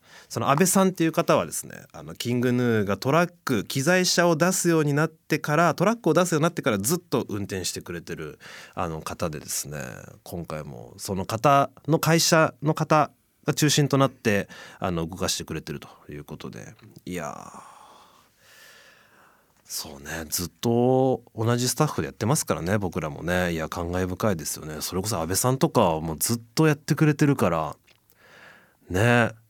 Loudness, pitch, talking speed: -24 LUFS, 125 Hz, 350 characters per minute